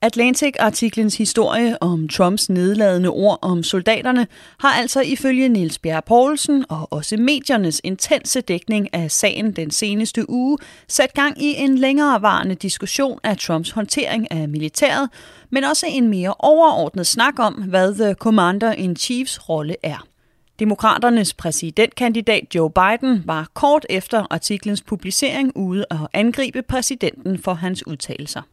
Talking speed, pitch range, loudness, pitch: 135 wpm, 185-255 Hz, -18 LUFS, 220 Hz